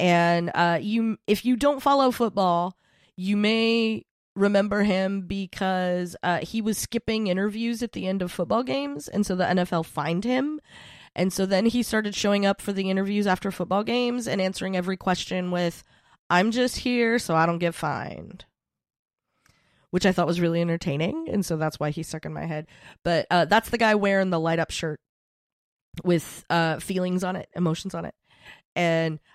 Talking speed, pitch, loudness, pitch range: 185 wpm, 185 Hz, -25 LUFS, 170-210 Hz